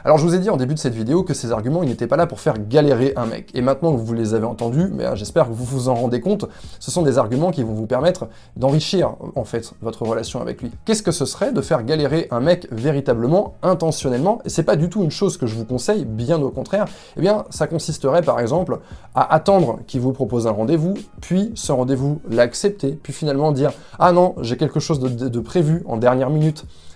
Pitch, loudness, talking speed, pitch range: 140 Hz, -19 LUFS, 240 wpm, 120-170 Hz